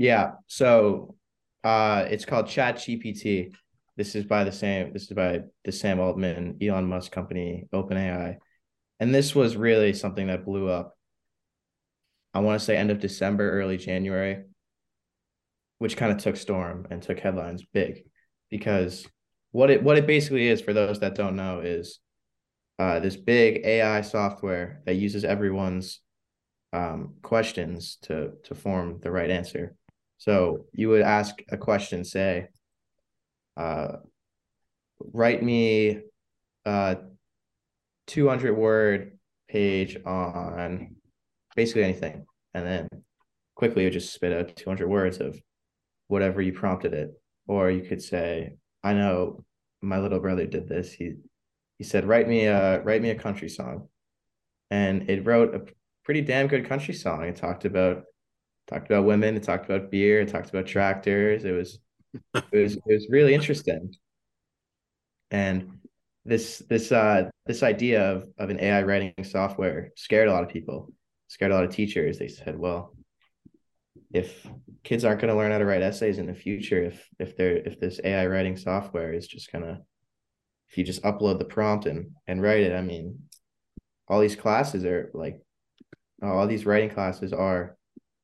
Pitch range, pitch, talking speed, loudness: 95-110 Hz, 100 Hz, 160 wpm, -26 LUFS